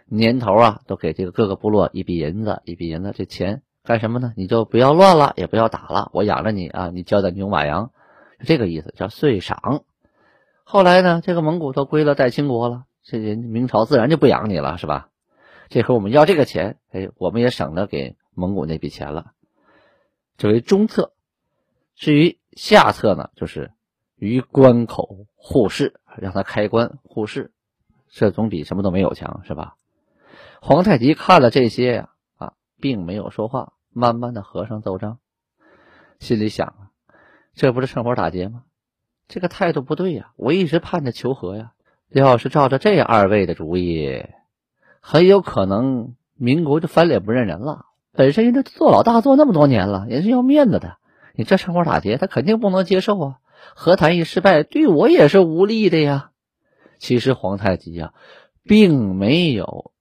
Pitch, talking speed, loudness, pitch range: 120 Hz, 265 characters per minute, -17 LUFS, 100-160 Hz